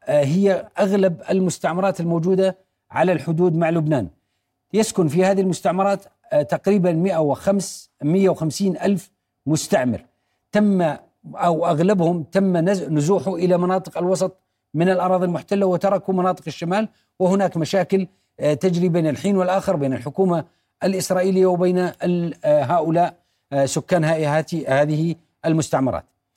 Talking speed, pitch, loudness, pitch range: 105 wpm, 180 Hz, -20 LUFS, 160-190 Hz